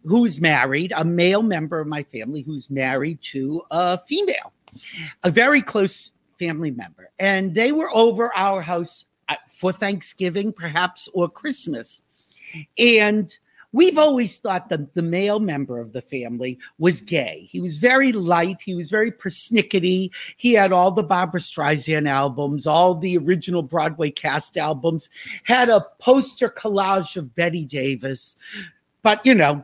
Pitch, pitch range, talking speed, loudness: 180 Hz, 155-210 Hz, 150 wpm, -20 LUFS